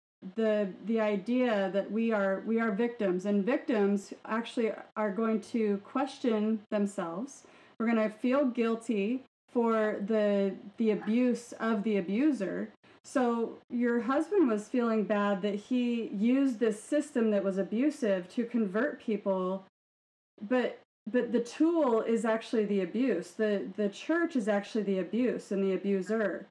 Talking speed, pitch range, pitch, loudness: 145 wpm, 205-245 Hz, 220 Hz, -31 LUFS